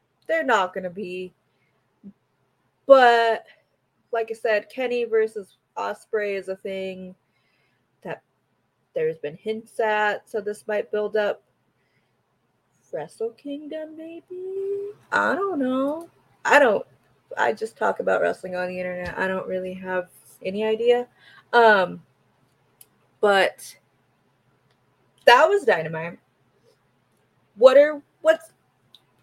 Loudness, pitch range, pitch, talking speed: -22 LUFS, 180-275 Hz, 210 Hz, 110 wpm